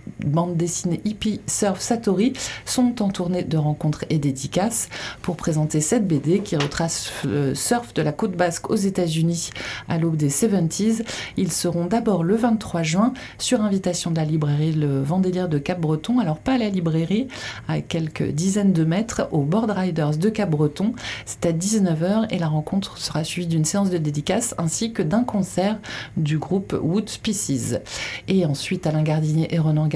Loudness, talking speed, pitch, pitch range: -22 LUFS, 175 wpm, 175 Hz, 155-200 Hz